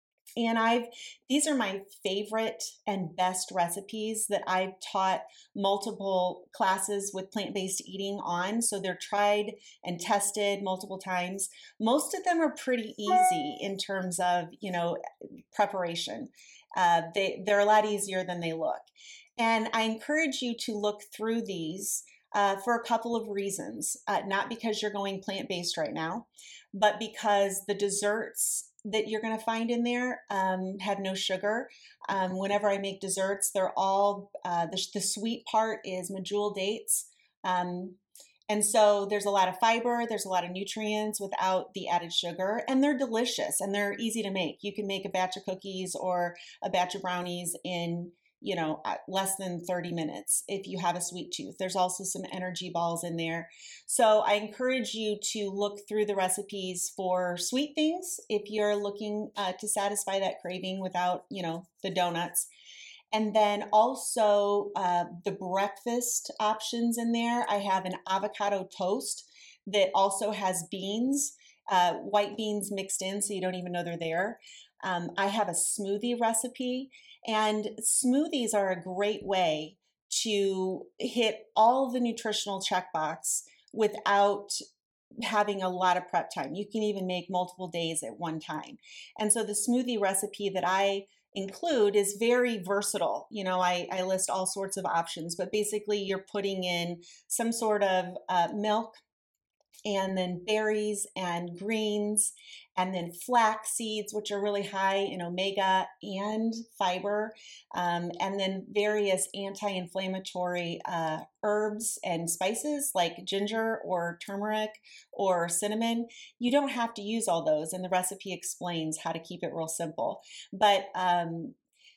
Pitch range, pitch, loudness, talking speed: 185-215 Hz, 200 Hz, -30 LUFS, 160 wpm